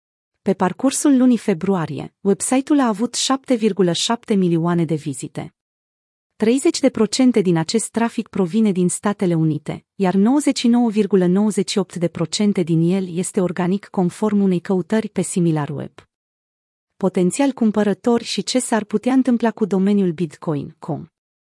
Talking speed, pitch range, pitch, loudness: 115 wpm, 175-230 Hz, 195 Hz, -19 LUFS